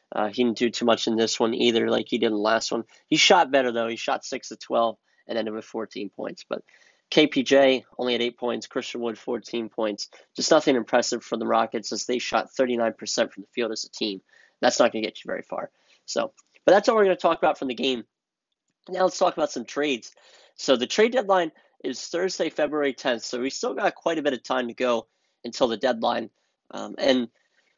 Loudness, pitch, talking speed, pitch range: -24 LUFS, 120 Hz, 230 wpm, 115-140 Hz